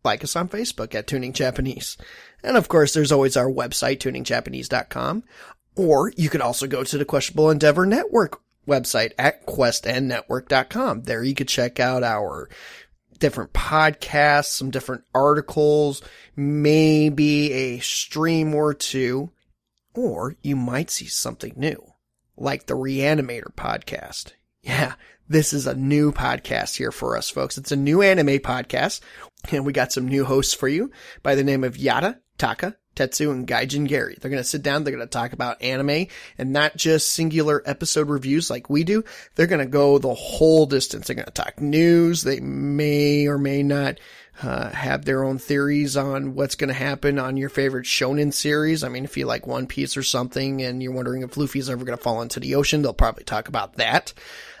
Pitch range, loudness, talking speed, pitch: 130-150 Hz, -22 LUFS, 175 wpm, 140 Hz